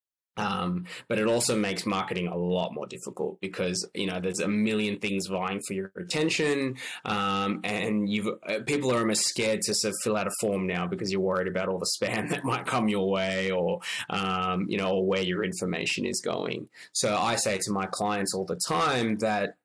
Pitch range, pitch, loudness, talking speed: 95-110 Hz, 100 Hz, -28 LUFS, 210 wpm